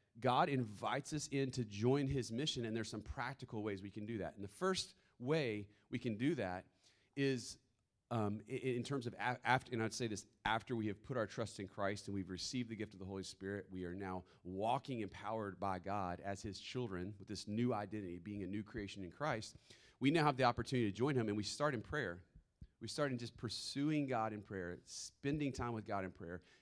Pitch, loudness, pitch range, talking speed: 110 Hz, -41 LUFS, 100-125 Hz, 230 wpm